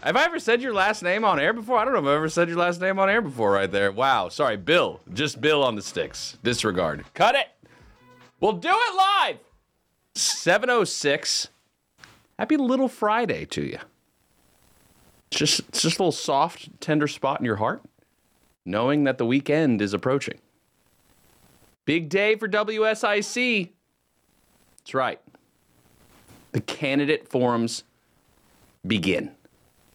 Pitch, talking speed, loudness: 160 Hz, 145 wpm, -23 LUFS